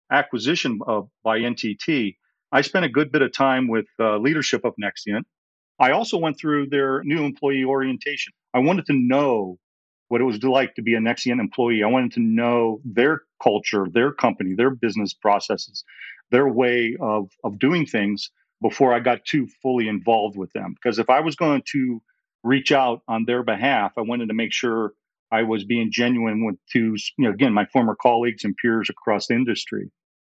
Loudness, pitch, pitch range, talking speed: -21 LUFS, 120 Hz, 110-130 Hz, 190 wpm